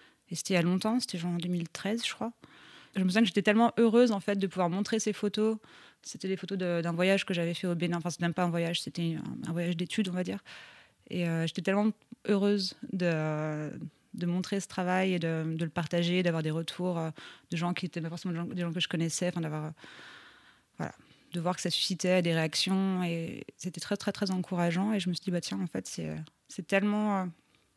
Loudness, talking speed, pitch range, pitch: -31 LUFS, 235 wpm, 170-200 Hz, 180 Hz